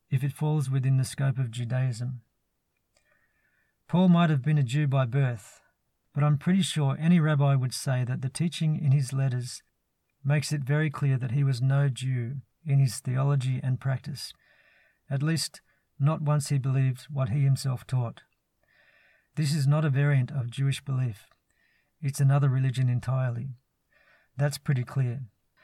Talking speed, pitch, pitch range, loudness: 160 wpm, 135 Hz, 130-145 Hz, -27 LUFS